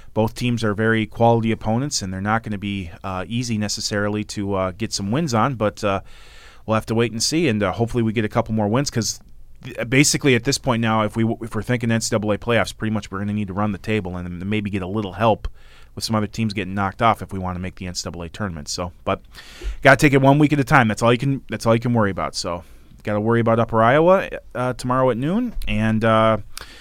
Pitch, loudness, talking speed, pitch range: 110 Hz, -20 LUFS, 265 wpm, 100-115 Hz